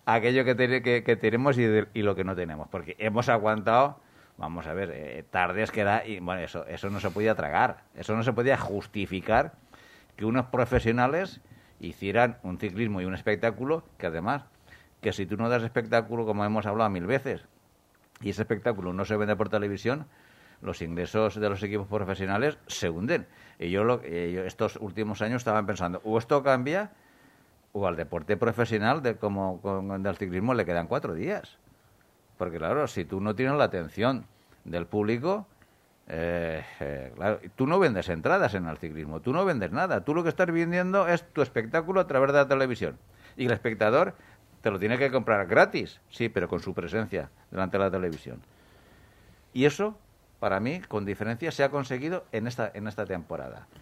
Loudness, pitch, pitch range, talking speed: -28 LUFS, 110 Hz, 95-125 Hz, 185 wpm